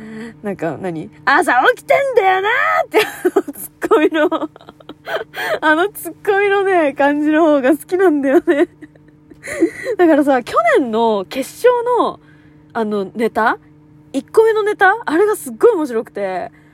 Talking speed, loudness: 280 characters per minute, -15 LUFS